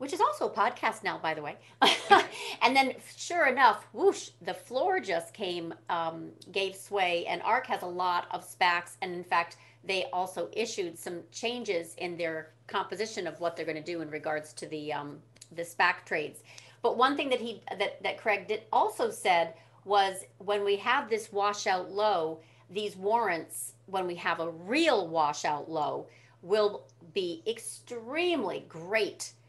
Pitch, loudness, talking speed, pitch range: 190 Hz, -30 LUFS, 170 wpm, 165-225 Hz